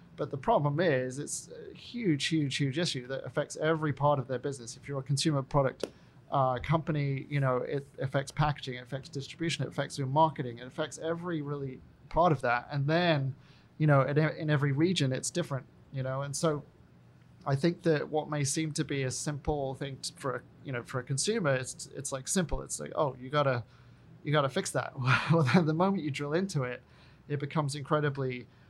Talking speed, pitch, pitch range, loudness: 205 wpm, 145 Hz, 135-155 Hz, -31 LUFS